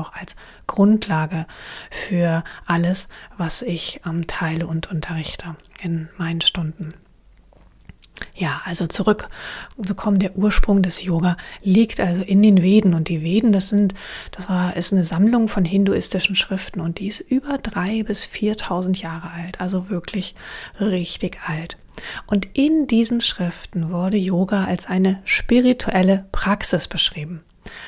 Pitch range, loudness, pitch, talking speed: 170-205 Hz, -20 LUFS, 185 Hz, 140 wpm